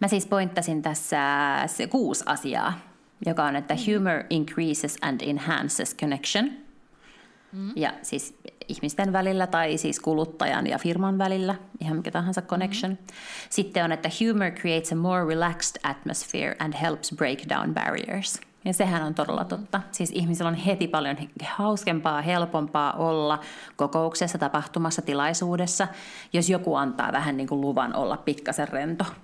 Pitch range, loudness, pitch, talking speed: 155-195 Hz, -26 LUFS, 170 Hz, 140 wpm